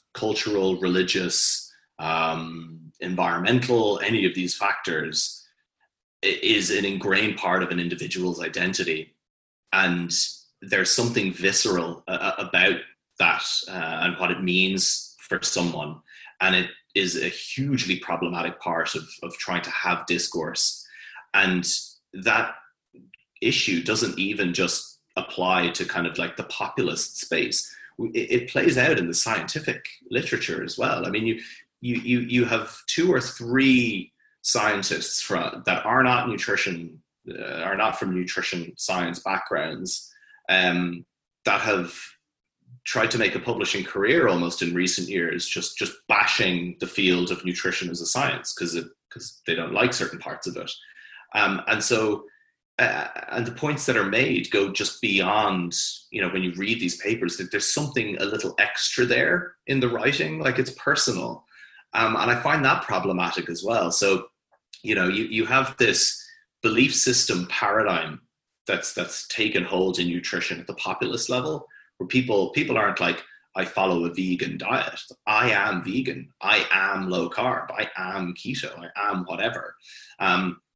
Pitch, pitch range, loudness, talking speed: 95 Hz, 90-130 Hz, -23 LUFS, 150 wpm